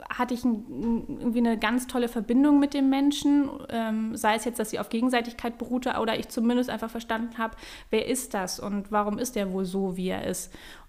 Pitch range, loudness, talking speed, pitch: 220-250 Hz, -27 LUFS, 200 wpm, 235 Hz